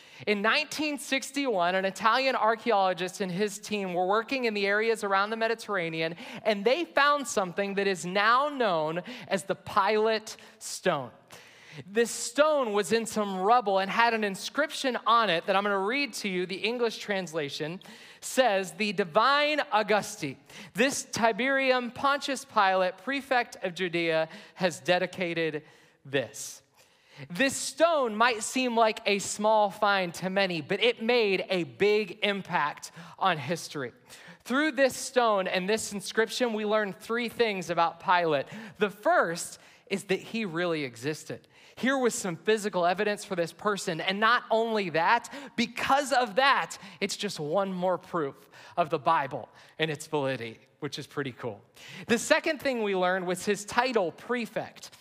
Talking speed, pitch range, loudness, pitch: 155 wpm, 180-235 Hz, -28 LUFS, 205 Hz